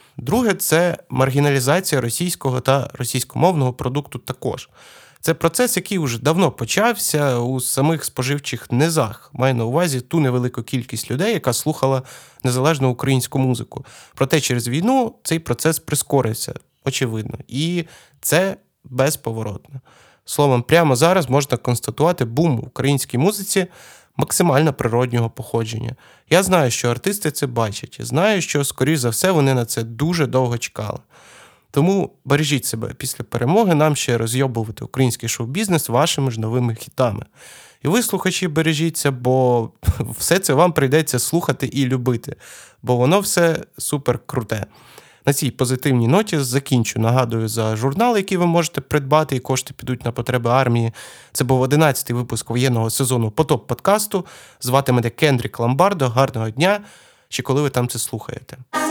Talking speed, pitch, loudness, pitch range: 140 wpm, 135 Hz, -19 LUFS, 125-160 Hz